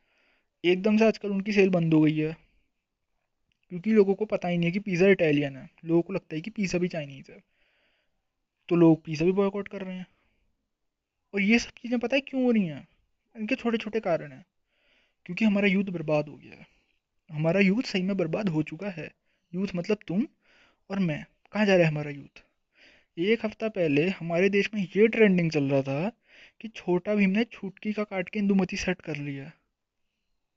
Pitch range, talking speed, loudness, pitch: 165-215 Hz, 200 wpm, -26 LUFS, 195 Hz